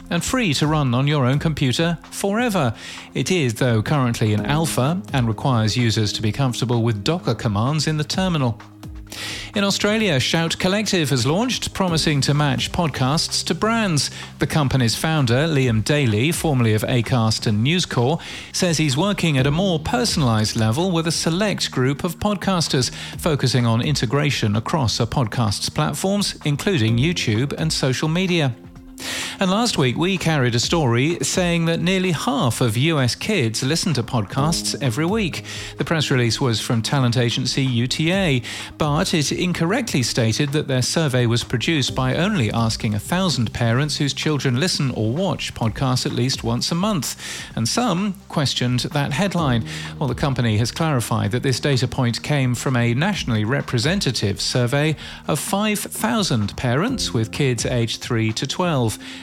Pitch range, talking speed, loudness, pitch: 120-165 Hz, 160 wpm, -20 LUFS, 135 Hz